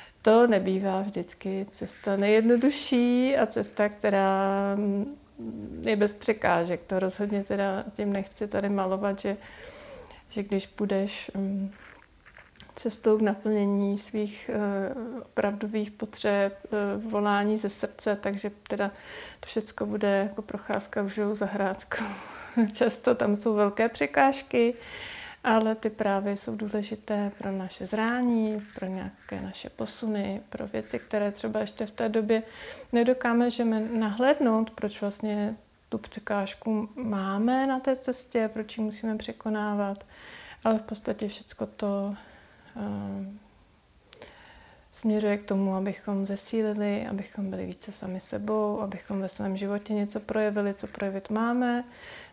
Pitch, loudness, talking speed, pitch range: 210 Hz, -28 LUFS, 120 wpm, 200-225 Hz